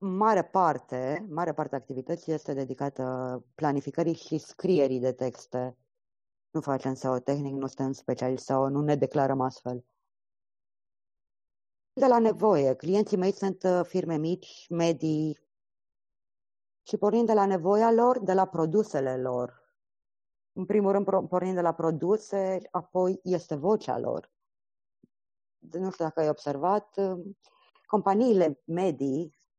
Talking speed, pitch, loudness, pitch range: 125 wpm, 160 Hz, -28 LUFS, 130-190 Hz